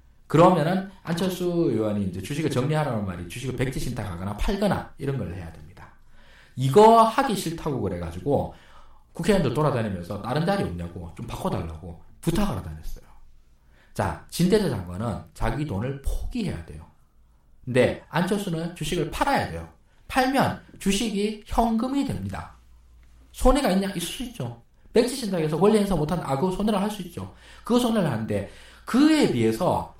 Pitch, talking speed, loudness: 135 Hz, 345 characters per minute, -24 LUFS